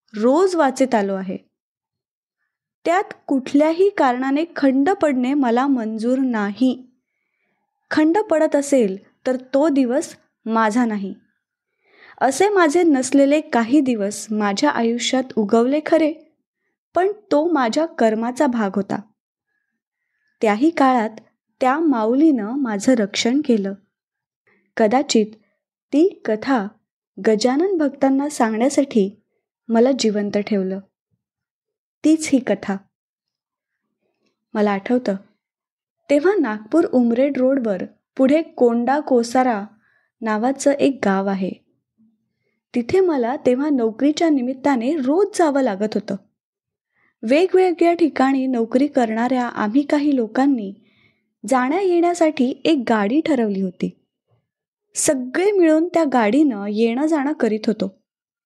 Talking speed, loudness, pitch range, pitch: 100 wpm, -19 LUFS, 225-310 Hz, 260 Hz